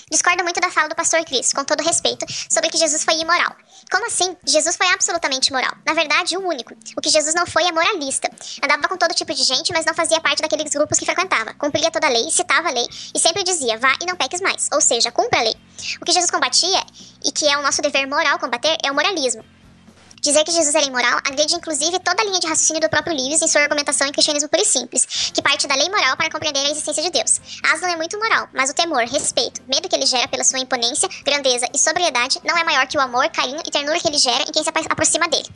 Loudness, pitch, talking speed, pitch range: -17 LUFS, 315 Hz, 255 wpm, 285-340 Hz